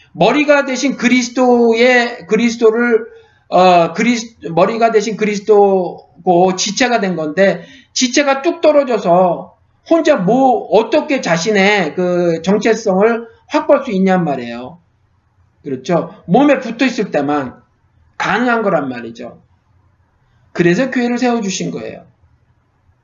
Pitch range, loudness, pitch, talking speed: 165-245 Hz, -13 LUFS, 205 Hz, 260 characters per minute